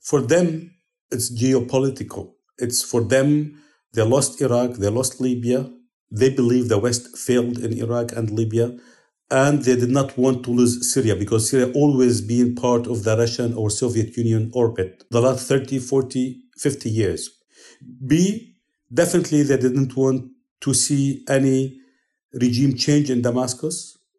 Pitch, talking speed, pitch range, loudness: 130 Hz, 150 wpm, 120-135 Hz, -20 LUFS